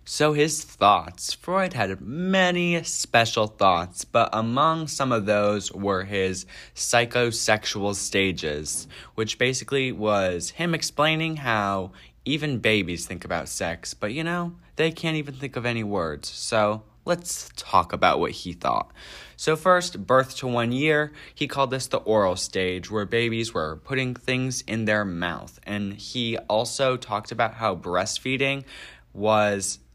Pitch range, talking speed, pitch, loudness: 100-140 Hz, 145 wpm, 115 Hz, -24 LUFS